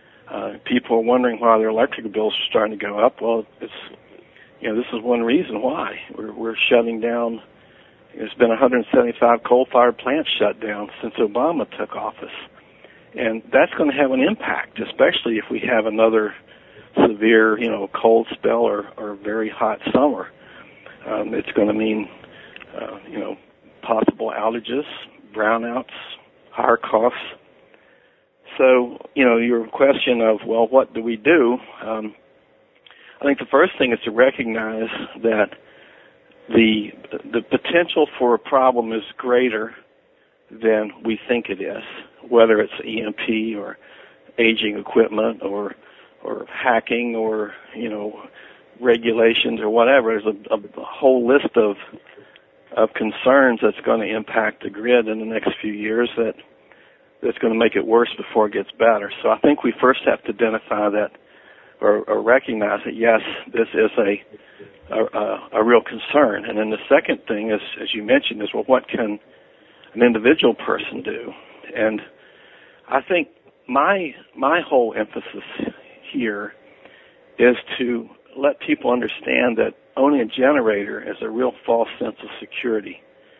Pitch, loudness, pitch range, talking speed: 115 Hz, -19 LUFS, 110-120 Hz, 155 wpm